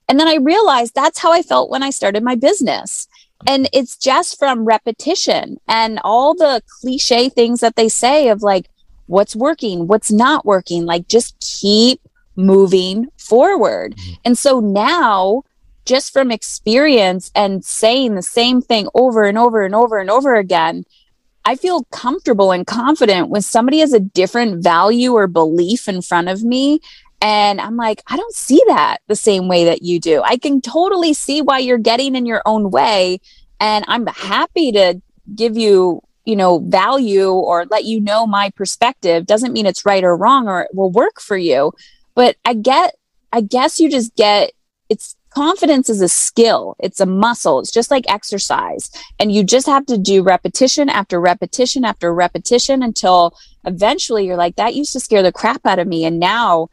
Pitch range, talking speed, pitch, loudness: 195-260 Hz, 180 wpm, 225 Hz, -14 LUFS